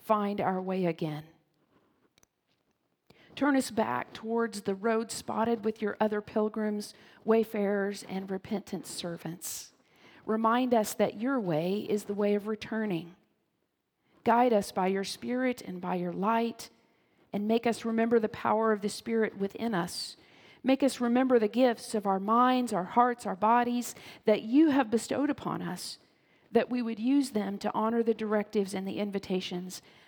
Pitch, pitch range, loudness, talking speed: 215 Hz, 195-230 Hz, -30 LUFS, 160 wpm